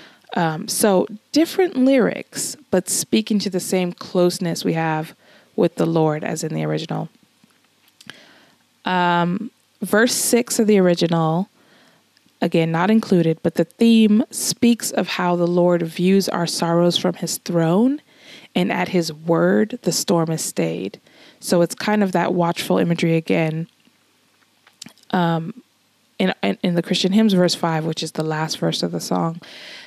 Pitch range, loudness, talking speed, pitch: 165-210 Hz, -19 LUFS, 150 wpm, 175 Hz